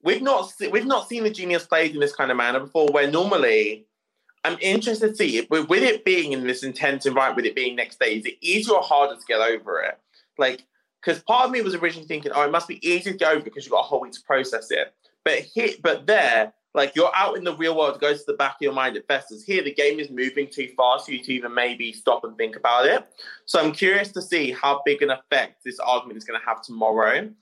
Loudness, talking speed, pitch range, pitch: -22 LUFS, 265 wpm, 135-215 Hz, 150 Hz